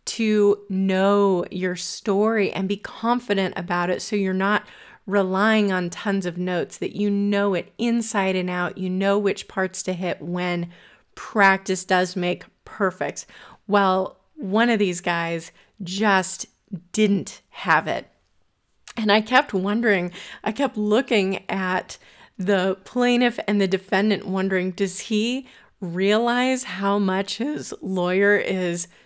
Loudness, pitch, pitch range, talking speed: -22 LUFS, 195 Hz, 185-210 Hz, 135 wpm